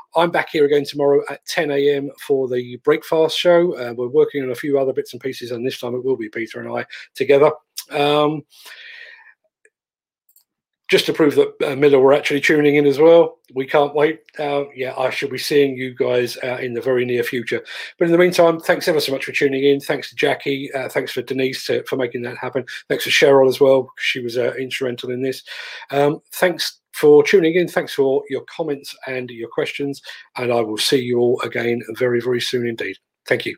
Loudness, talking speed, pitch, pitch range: -18 LUFS, 220 wpm, 140 Hz, 125-155 Hz